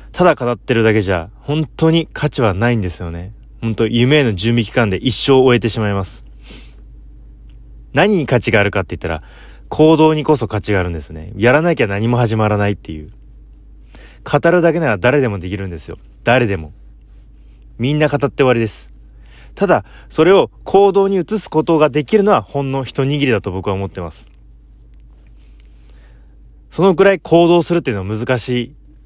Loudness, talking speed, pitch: -15 LUFS, 345 characters per minute, 110 Hz